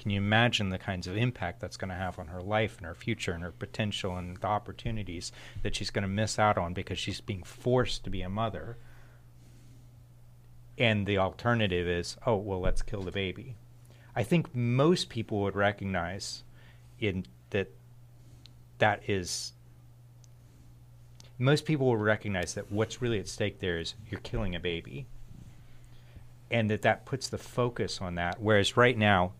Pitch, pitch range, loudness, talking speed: 110 Hz, 95-120 Hz, -31 LUFS, 170 wpm